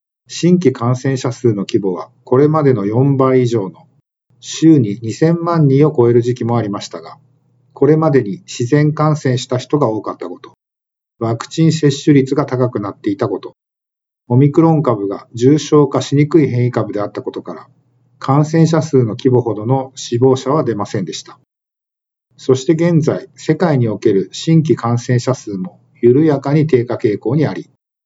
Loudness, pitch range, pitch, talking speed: -14 LUFS, 120-150 Hz, 130 Hz, 315 characters per minute